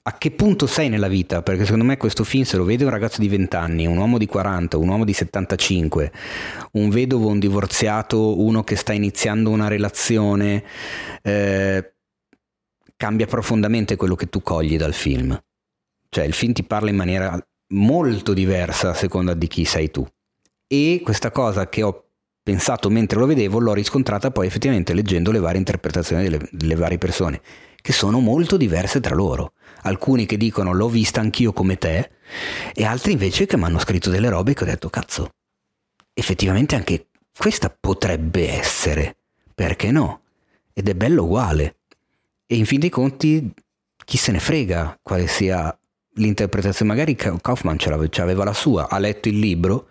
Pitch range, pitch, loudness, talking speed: 90-110 Hz, 100 Hz, -20 LUFS, 175 wpm